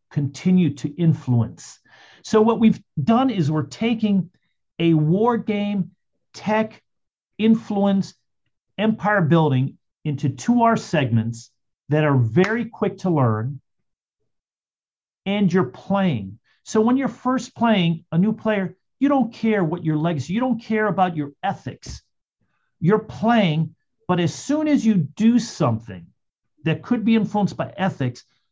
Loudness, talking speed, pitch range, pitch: -21 LUFS, 135 wpm, 150-220 Hz, 185 Hz